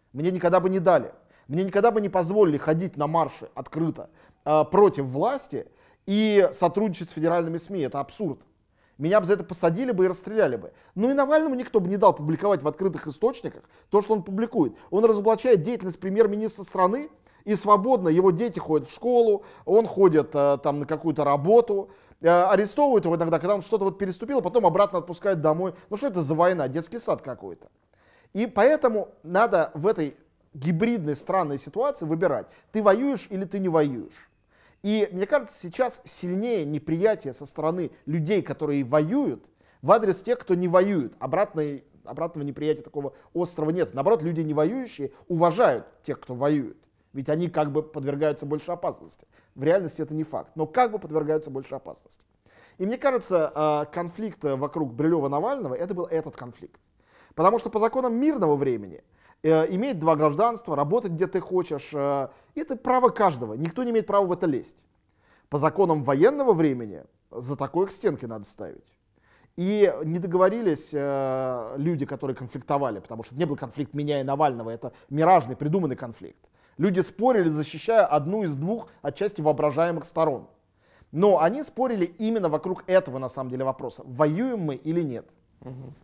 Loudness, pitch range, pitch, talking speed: -24 LUFS, 145-205 Hz, 170 Hz, 165 wpm